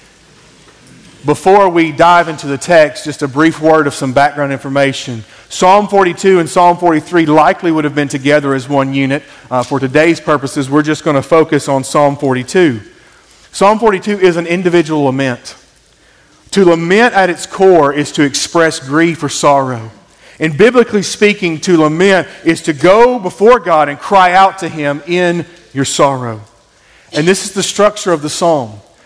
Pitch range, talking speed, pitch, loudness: 140-180 Hz, 170 wpm, 160 Hz, -11 LUFS